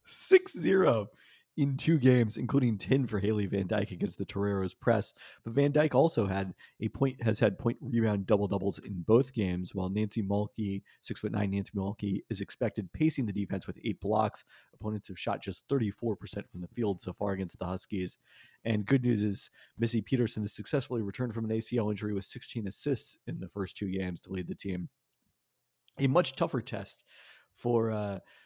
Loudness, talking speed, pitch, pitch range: -31 LUFS, 190 wpm, 105 Hz, 100-120 Hz